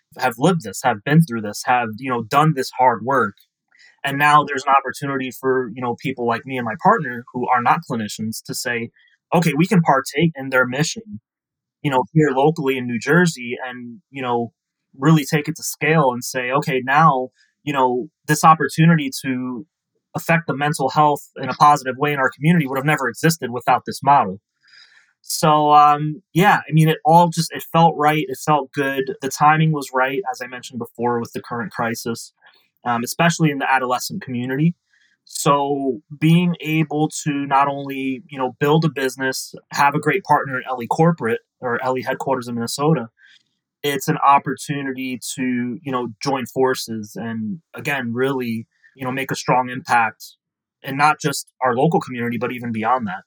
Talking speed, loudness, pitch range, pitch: 185 wpm, -19 LUFS, 125-155 Hz, 135 Hz